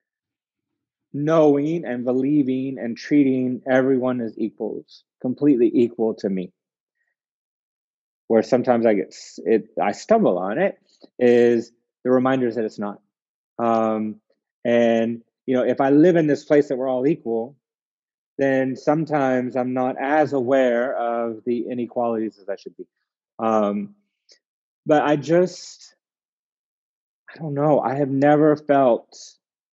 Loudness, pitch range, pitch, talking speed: -21 LUFS, 115-145 Hz, 130 Hz, 130 wpm